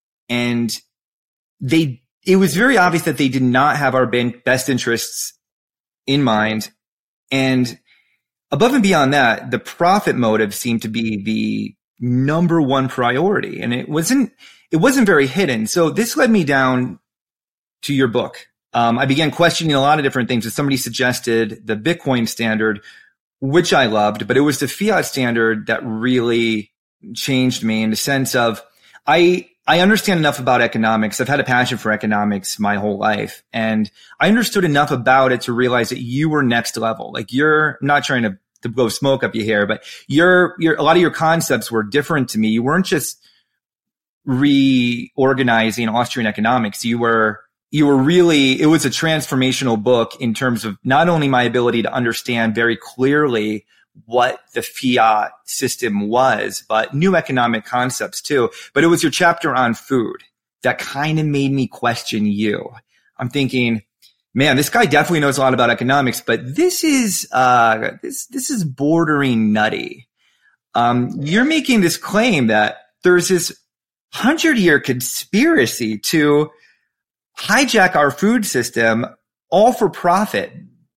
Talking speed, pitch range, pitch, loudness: 165 wpm, 115-155 Hz, 130 Hz, -16 LUFS